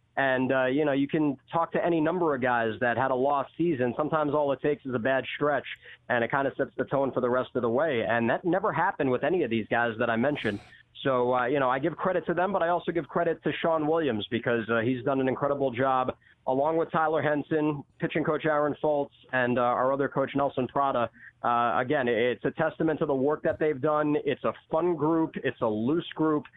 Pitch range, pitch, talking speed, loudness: 125-155 Hz, 140 Hz, 245 wpm, -27 LUFS